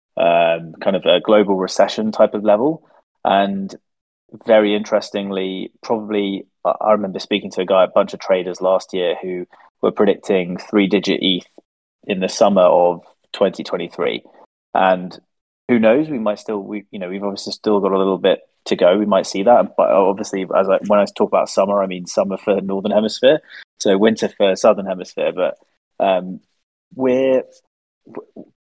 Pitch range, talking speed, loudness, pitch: 95-105 Hz, 170 wpm, -17 LUFS, 100 Hz